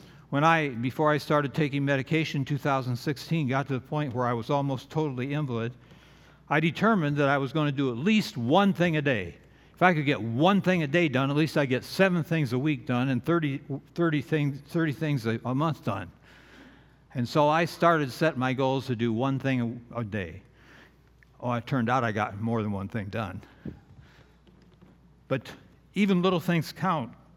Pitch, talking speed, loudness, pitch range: 140 Hz, 195 wpm, -27 LUFS, 125-160 Hz